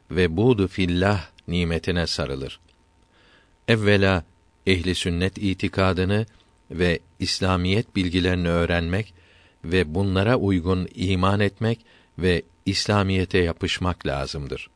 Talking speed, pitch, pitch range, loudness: 90 wpm, 90 Hz, 85-95 Hz, -23 LUFS